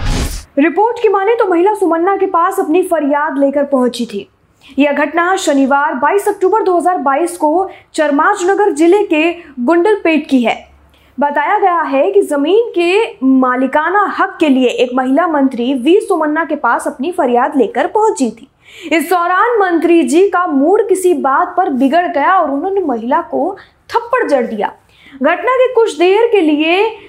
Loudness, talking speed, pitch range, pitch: -12 LUFS, 160 wpm, 290-390 Hz, 340 Hz